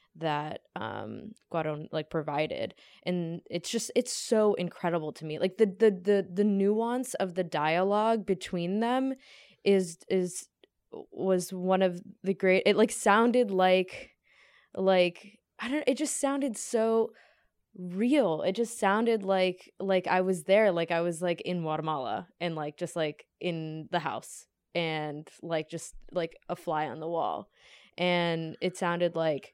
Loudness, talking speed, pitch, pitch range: -29 LUFS, 155 wpm, 185 Hz, 170-215 Hz